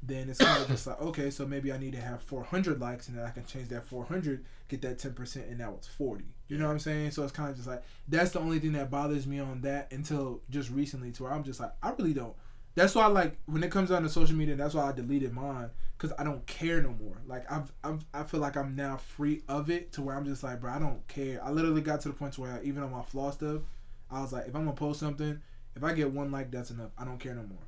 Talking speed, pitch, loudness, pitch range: 295 wpm, 140 Hz, -34 LUFS, 125-150 Hz